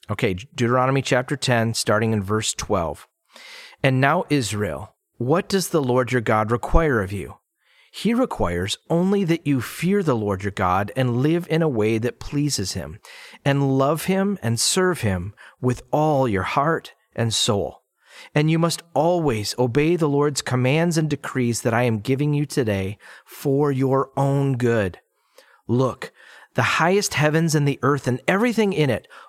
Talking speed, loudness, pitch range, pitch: 165 wpm, -21 LUFS, 115-155 Hz, 135 Hz